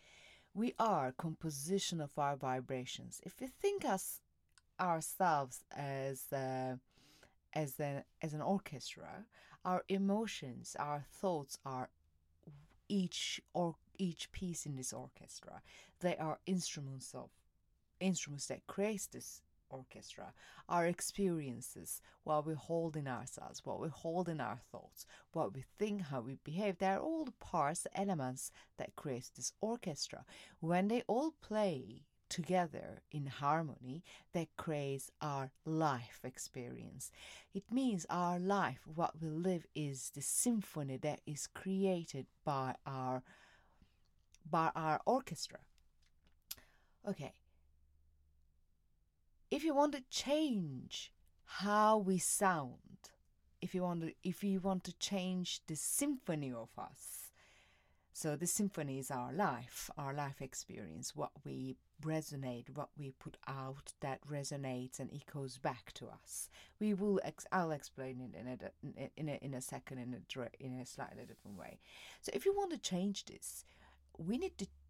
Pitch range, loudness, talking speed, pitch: 130-185 Hz, -41 LUFS, 140 wpm, 150 Hz